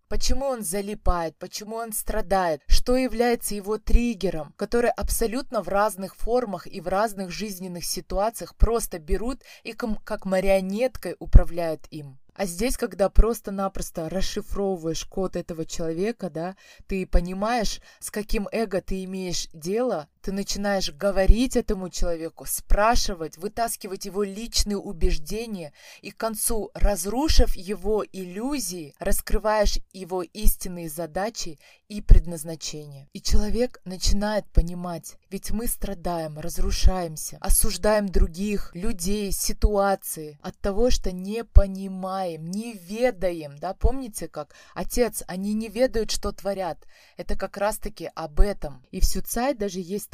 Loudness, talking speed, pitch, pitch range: -27 LUFS, 125 wpm, 195 Hz, 180-215 Hz